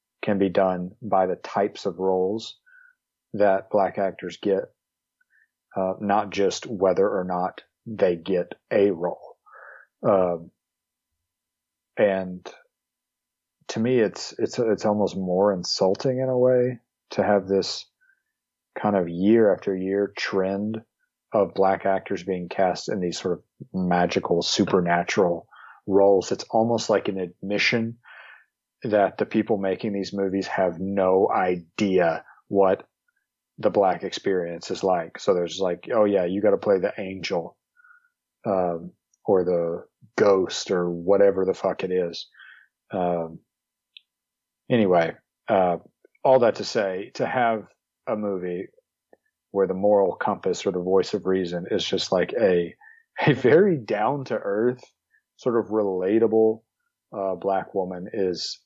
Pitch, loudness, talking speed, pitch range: 95 Hz, -24 LUFS, 135 wpm, 90-110 Hz